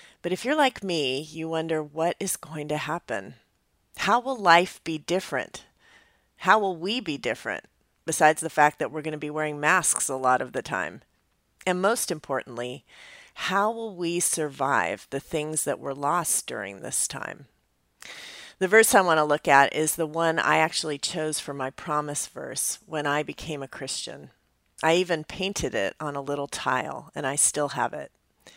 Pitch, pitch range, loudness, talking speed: 155 Hz, 145-180 Hz, -25 LUFS, 185 wpm